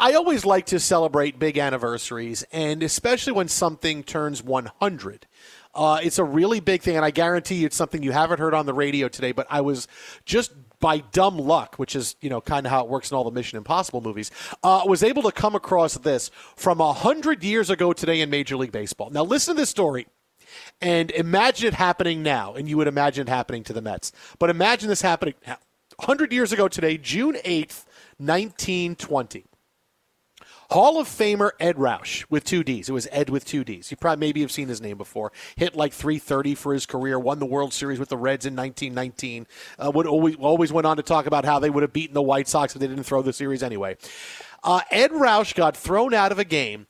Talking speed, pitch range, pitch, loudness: 220 wpm, 135-185 Hz, 155 Hz, -23 LUFS